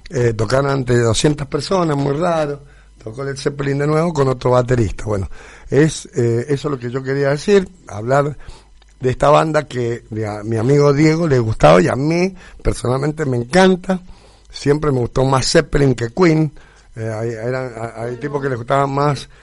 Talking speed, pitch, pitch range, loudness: 175 wpm, 140 Hz, 120-150 Hz, -17 LUFS